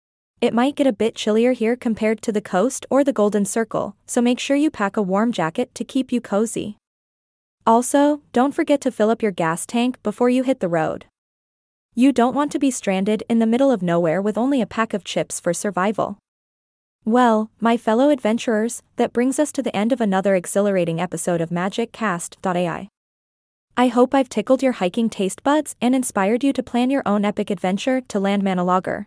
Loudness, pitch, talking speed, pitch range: -20 LUFS, 225 Hz, 200 wpm, 195-250 Hz